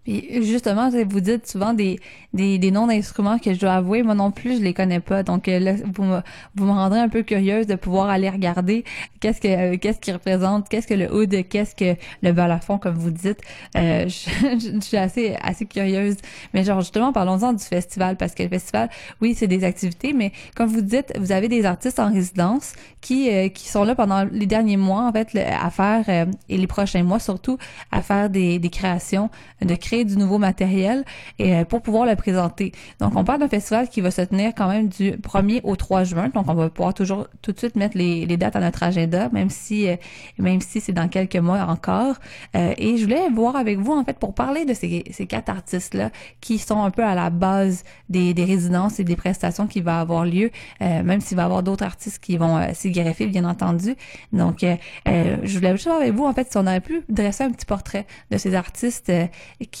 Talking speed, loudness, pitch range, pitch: 230 wpm, -21 LUFS, 185-220 Hz, 195 Hz